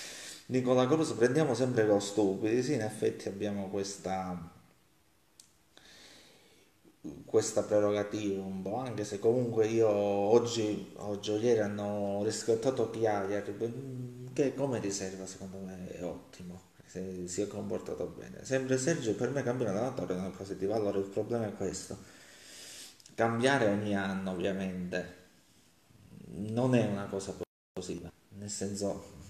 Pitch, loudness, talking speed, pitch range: 100 Hz, -32 LUFS, 135 wpm, 95-115 Hz